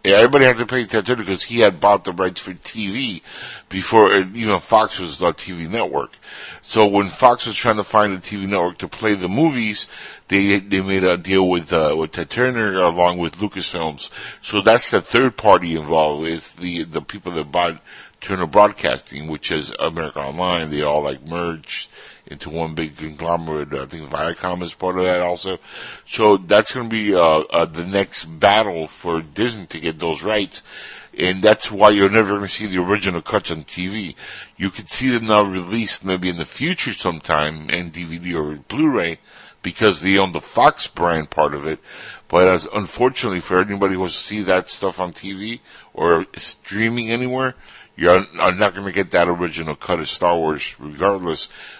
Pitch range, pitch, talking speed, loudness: 85-105 Hz, 95 Hz, 195 wpm, -19 LUFS